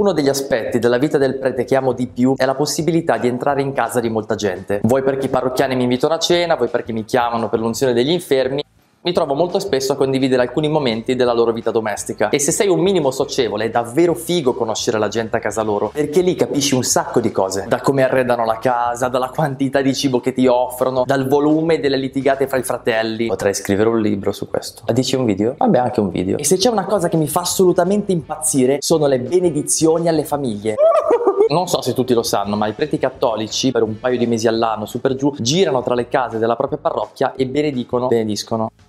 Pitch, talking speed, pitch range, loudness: 130 Hz, 230 wpm, 115-150 Hz, -17 LUFS